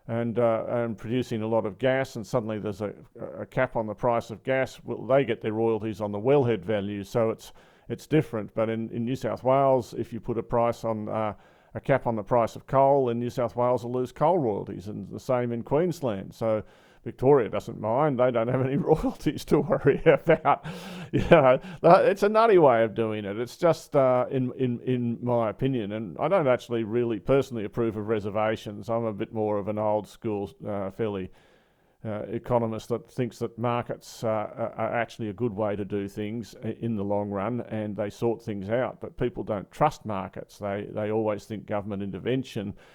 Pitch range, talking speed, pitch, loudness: 110-130 Hz, 205 wpm, 115 Hz, -26 LUFS